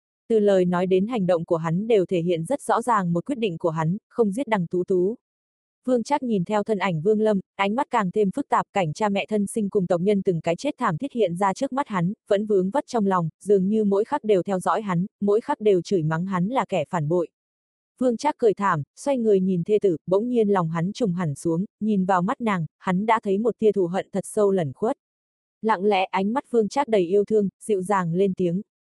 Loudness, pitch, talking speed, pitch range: -23 LUFS, 200 Hz, 255 wpm, 180-220 Hz